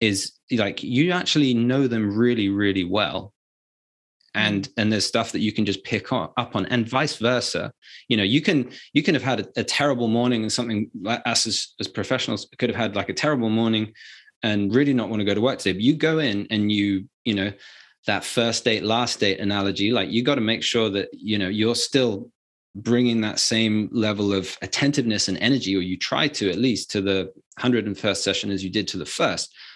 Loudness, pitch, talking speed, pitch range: -22 LUFS, 110 Hz, 215 wpm, 100-120 Hz